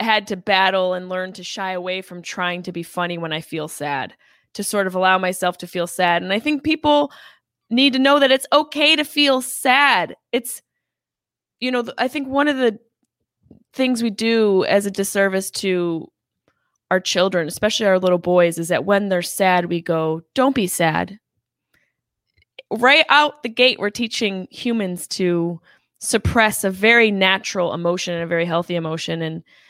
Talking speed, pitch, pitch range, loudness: 180 wpm, 190 Hz, 175-240 Hz, -19 LUFS